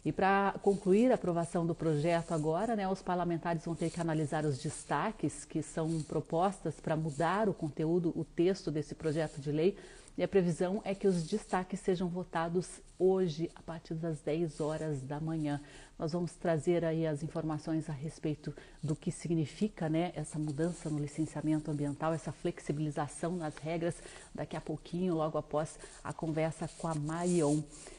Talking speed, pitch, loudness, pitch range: 165 wpm, 165 Hz, -34 LUFS, 155-175 Hz